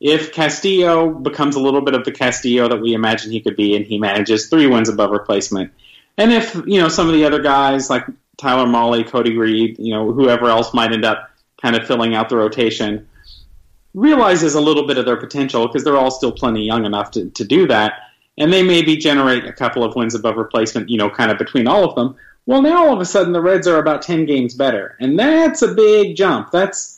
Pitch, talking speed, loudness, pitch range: 130 Hz, 230 wpm, -15 LUFS, 115-160 Hz